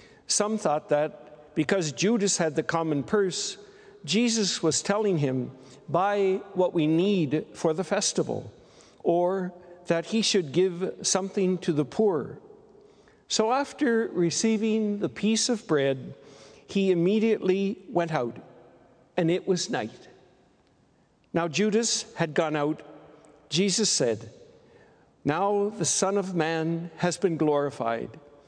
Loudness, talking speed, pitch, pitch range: -26 LUFS, 125 wpm, 180 Hz, 155-205 Hz